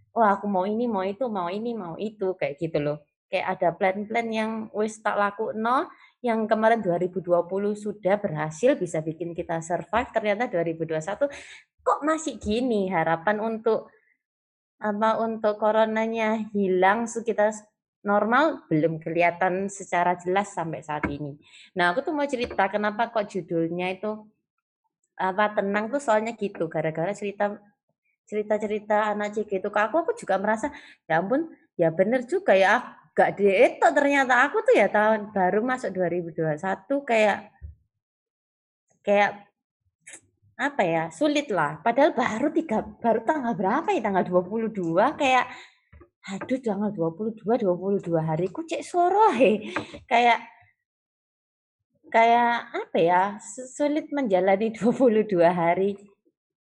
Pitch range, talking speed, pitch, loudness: 185-235 Hz, 130 wpm, 210 Hz, -25 LUFS